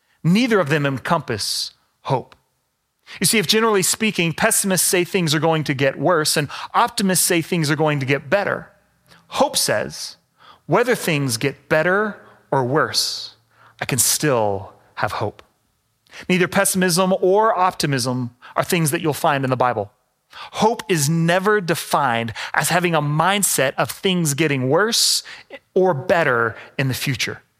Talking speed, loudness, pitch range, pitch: 150 wpm, -19 LUFS, 140-190 Hz, 165 Hz